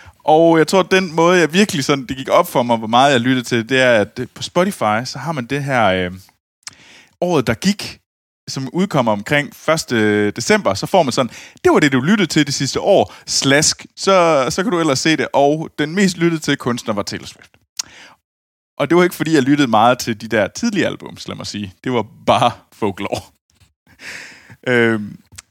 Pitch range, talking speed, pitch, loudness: 115-165 Hz, 210 wpm, 135 Hz, -16 LUFS